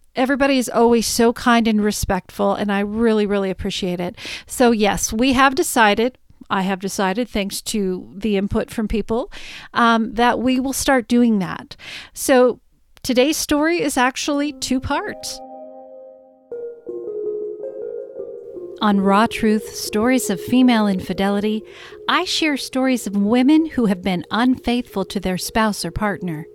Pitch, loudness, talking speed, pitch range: 230 Hz, -19 LUFS, 140 wpm, 200-265 Hz